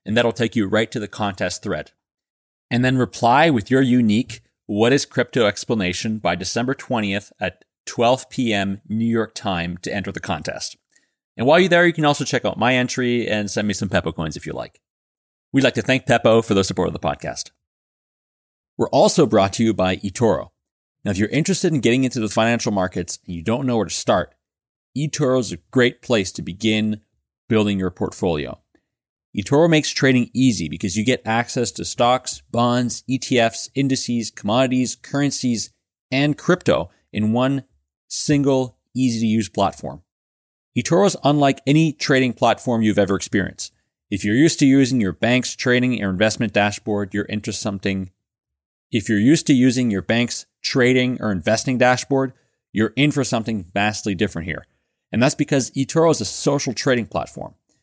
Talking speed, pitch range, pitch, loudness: 175 wpm, 105-130 Hz, 115 Hz, -20 LUFS